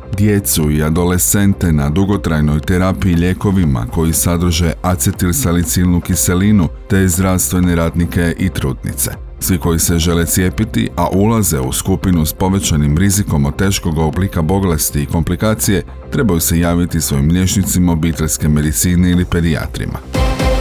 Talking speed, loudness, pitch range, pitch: 125 wpm, -14 LUFS, 80-95 Hz, 90 Hz